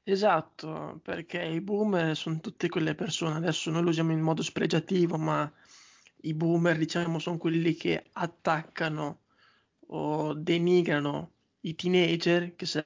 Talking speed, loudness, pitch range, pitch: 130 wpm, -29 LUFS, 160-175 Hz, 165 Hz